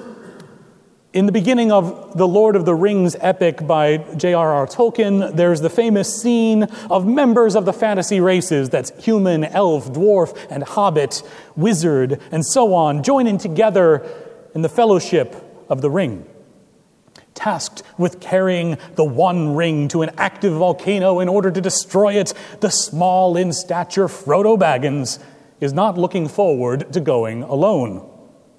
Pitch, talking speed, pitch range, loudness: 185 Hz, 145 wpm, 165-210 Hz, -17 LUFS